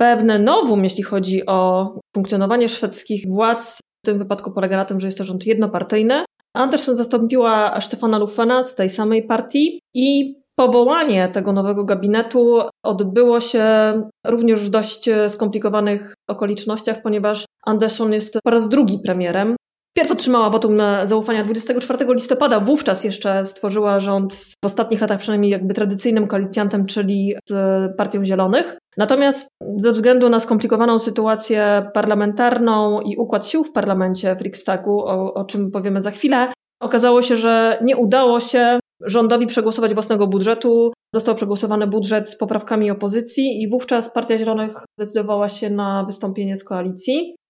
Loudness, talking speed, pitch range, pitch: -18 LUFS, 145 wpm, 205-235 Hz, 215 Hz